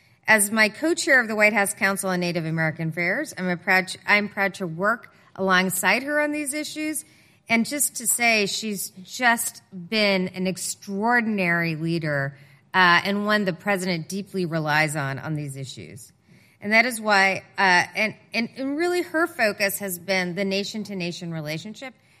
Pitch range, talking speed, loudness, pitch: 175-220 Hz, 165 wpm, -22 LUFS, 195 Hz